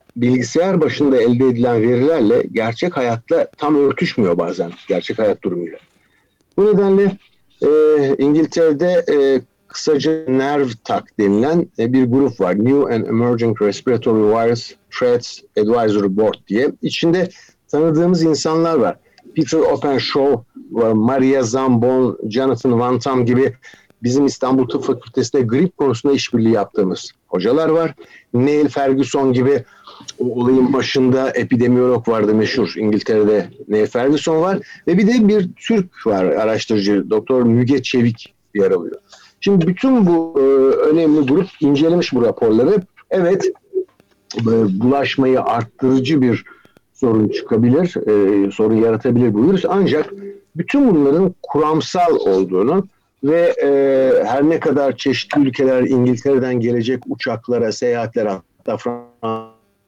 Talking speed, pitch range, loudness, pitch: 115 wpm, 120-160 Hz, -16 LUFS, 135 Hz